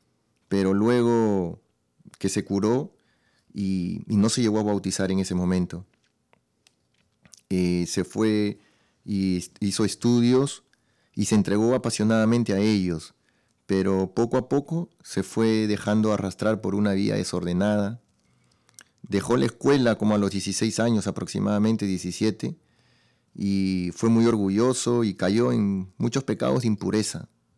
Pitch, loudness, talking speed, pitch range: 105 Hz, -24 LUFS, 130 wpm, 95-110 Hz